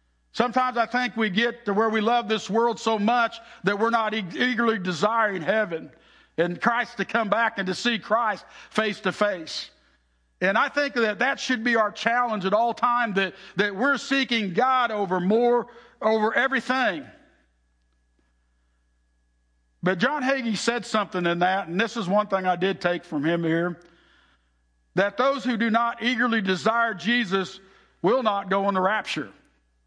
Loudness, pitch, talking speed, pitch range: -24 LUFS, 215 Hz, 165 wpm, 180-235 Hz